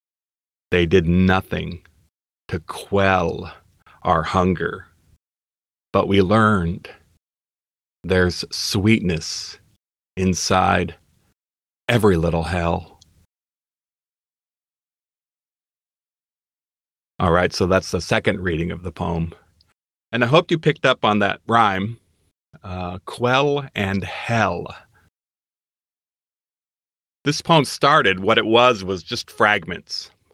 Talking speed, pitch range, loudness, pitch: 95 wpm, 85-110 Hz, -19 LUFS, 95 Hz